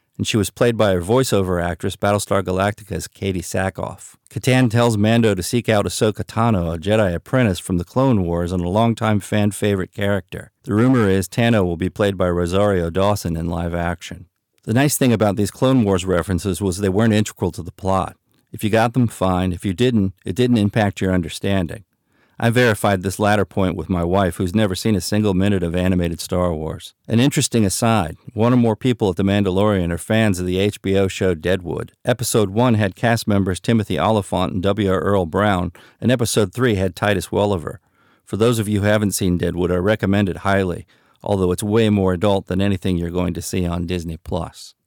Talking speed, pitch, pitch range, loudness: 205 wpm, 100 Hz, 90-110 Hz, -19 LUFS